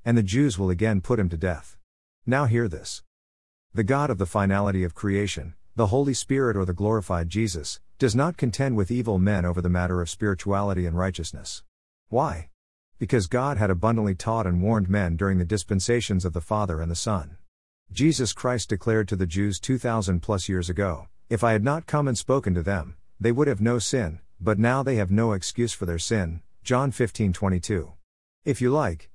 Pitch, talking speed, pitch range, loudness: 100 Hz, 195 wpm, 90-115 Hz, -25 LUFS